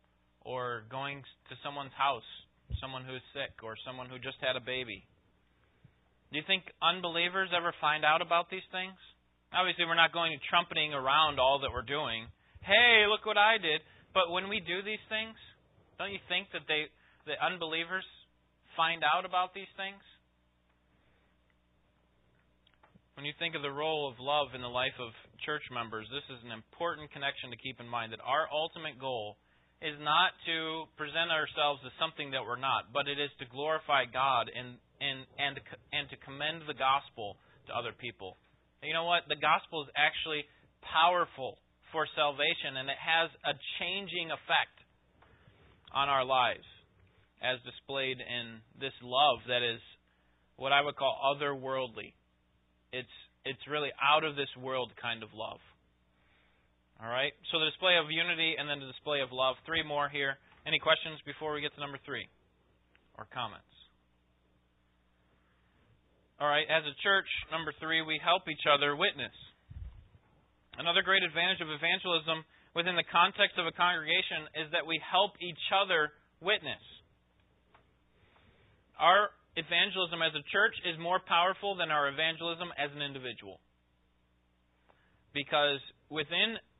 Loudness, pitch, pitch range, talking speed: -31 LUFS, 145 Hz, 120-165 Hz, 155 wpm